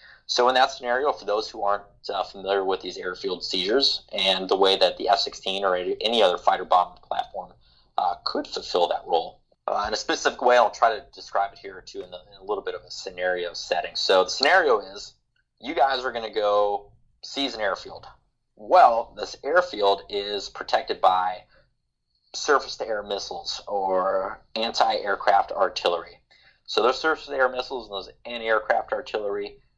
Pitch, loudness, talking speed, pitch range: 110 Hz, -24 LUFS, 185 wpm, 100-135 Hz